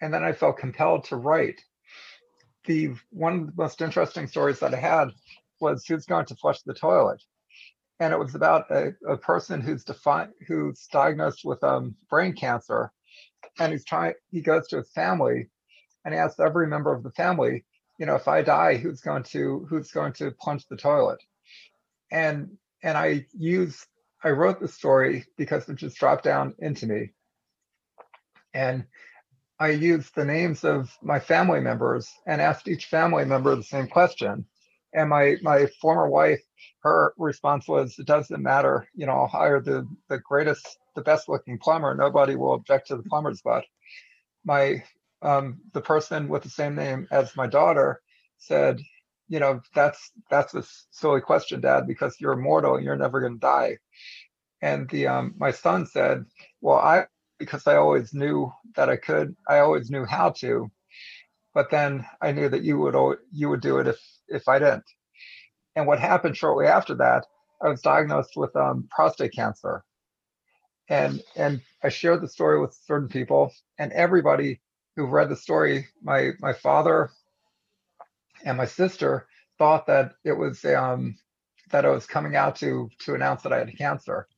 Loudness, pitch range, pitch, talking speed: -24 LUFS, 125-160 Hz, 145 Hz, 175 wpm